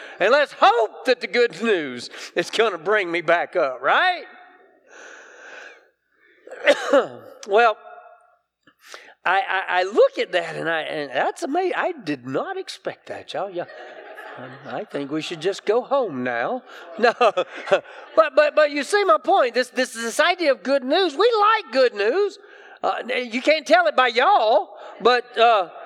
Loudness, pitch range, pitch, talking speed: -20 LUFS, 230-380 Hz, 300 Hz, 165 wpm